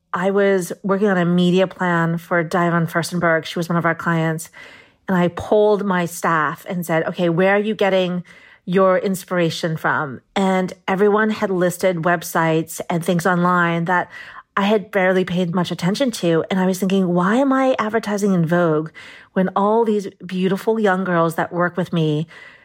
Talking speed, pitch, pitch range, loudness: 175 wpm, 180 Hz, 170-195 Hz, -19 LUFS